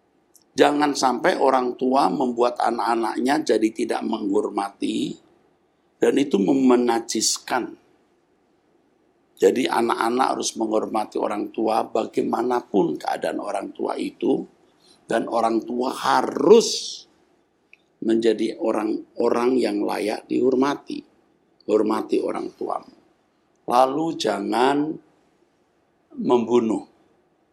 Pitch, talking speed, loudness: 320 Hz, 85 wpm, -22 LUFS